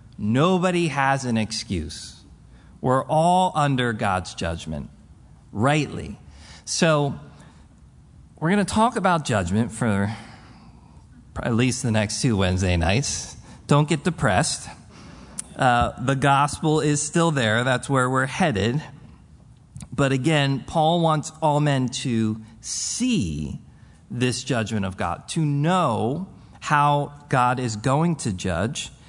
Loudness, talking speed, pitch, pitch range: -22 LUFS, 120 wpm, 130 Hz, 110-150 Hz